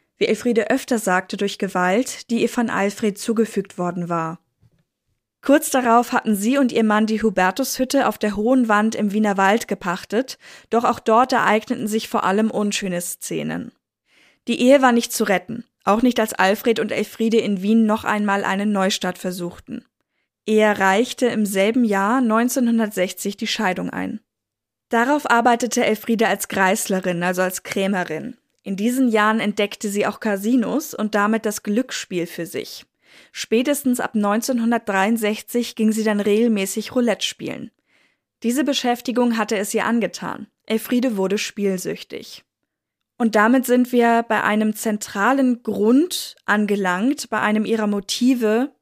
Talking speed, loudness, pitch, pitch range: 145 wpm, -20 LUFS, 220 Hz, 205-240 Hz